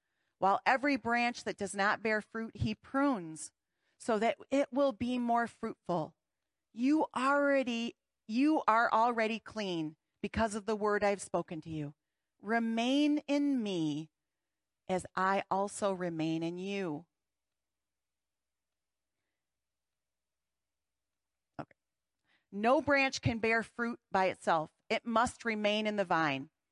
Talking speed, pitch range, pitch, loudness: 120 wpm, 170-235 Hz, 215 Hz, -33 LUFS